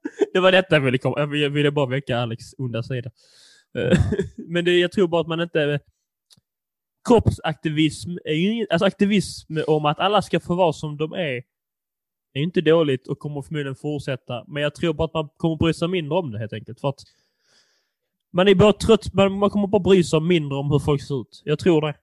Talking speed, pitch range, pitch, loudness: 205 wpm, 140-180 Hz, 155 Hz, -21 LUFS